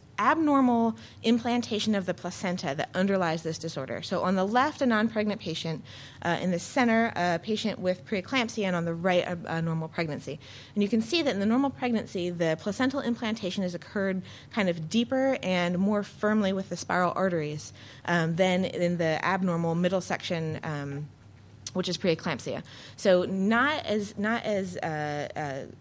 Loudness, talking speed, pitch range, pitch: -28 LUFS, 175 wpm, 165-215 Hz, 185 Hz